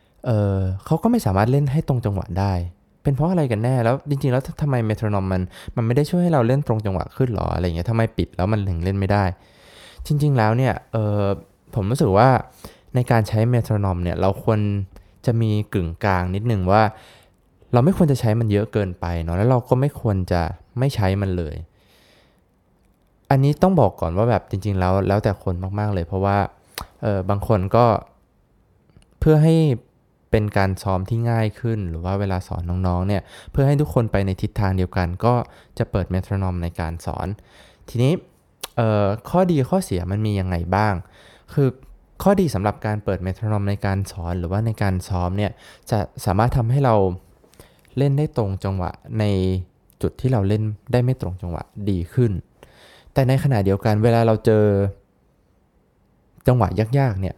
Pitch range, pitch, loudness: 95-120 Hz, 105 Hz, -21 LUFS